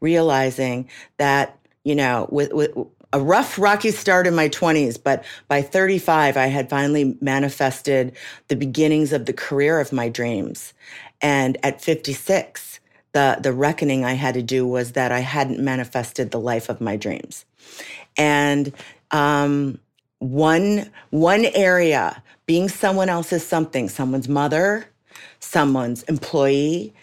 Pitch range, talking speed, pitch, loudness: 130-160 Hz, 135 wpm, 140 Hz, -20 LUFS